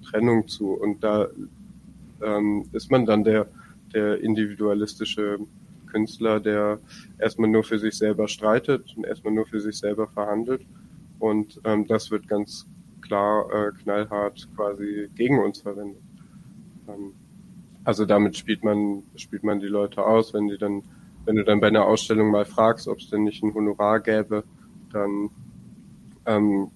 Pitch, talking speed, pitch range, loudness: 105 Hz, 150 wpm, 105-110 Hz, -24 LUFS